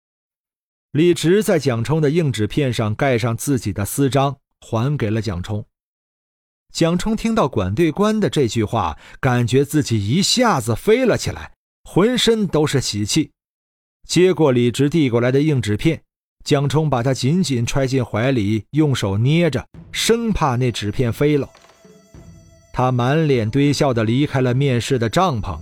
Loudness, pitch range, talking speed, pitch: -18 LUFS, 115-155 Hz, 225 characters per minute, 135 Hz